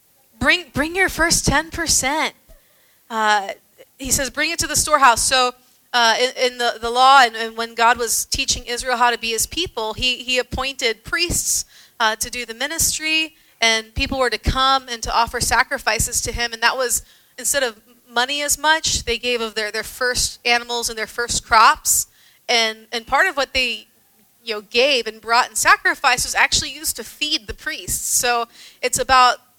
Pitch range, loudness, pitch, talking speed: 235-280 Hz, -18 LUFS, 245 Hz, 195 wpm